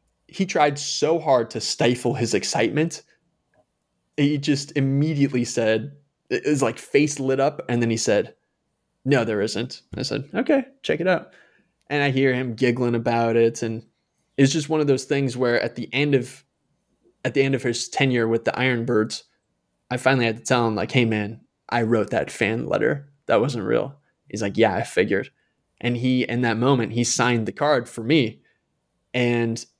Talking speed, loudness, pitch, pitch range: 185 wpm, -22 LUFS, 125 Hz, 115-140 Hz